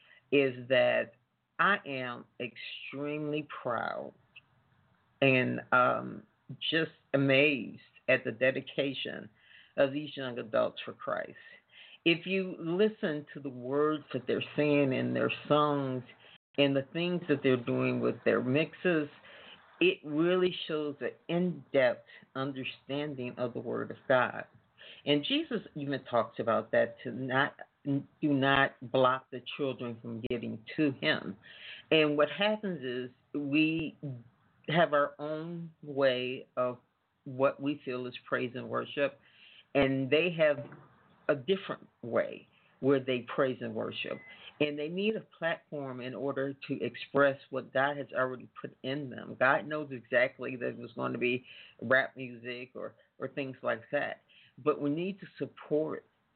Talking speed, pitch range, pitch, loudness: 145 wpm, 130-150 Hz, 140 Hz, -32 LUFS